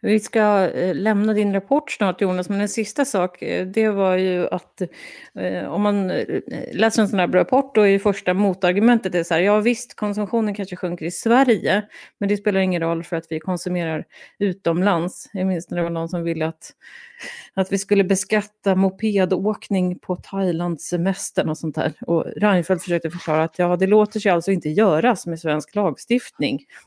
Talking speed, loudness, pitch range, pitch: 180 wpm, -21 LUFS, 175-215 Hz, 195 Hz